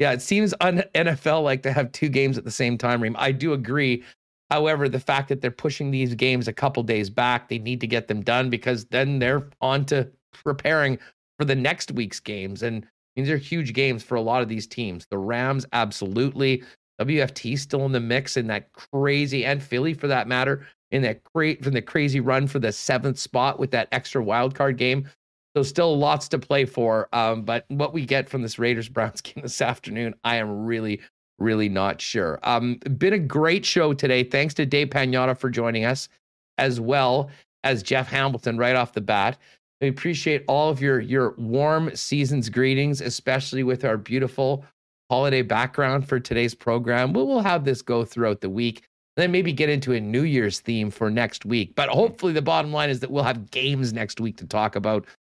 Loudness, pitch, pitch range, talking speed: -23 LUFS, 130 Hz, 120-140 Hz, 205 wpm